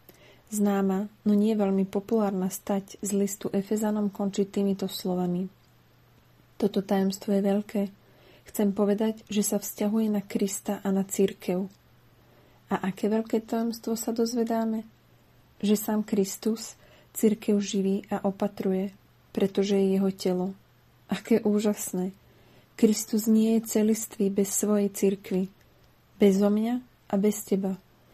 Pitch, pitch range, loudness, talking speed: 205 Hz, 195-215 Hz, -27 LUFS, 125 wpm